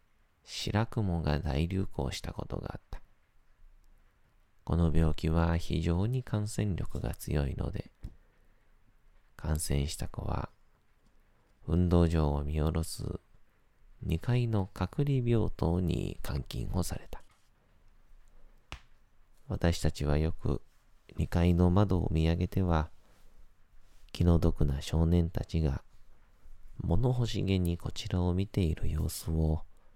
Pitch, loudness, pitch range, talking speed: 85 Hz, -32 LUFS, 80-95 Hz, 195 characters per minute